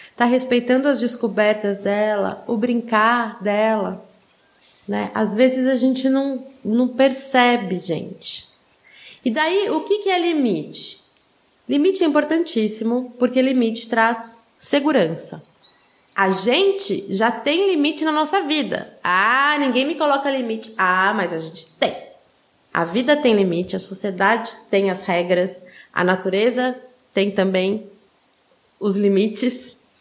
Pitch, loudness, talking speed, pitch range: 235 Hz, -20 LUFS, 130 wpm, 200-265 Hz